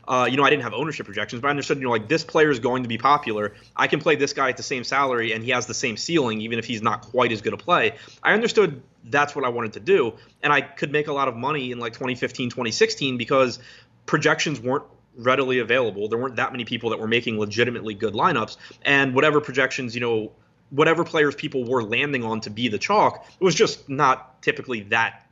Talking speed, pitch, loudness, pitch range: 240 wpm, 130 Hz, -22 LUFS, 115-145 Hz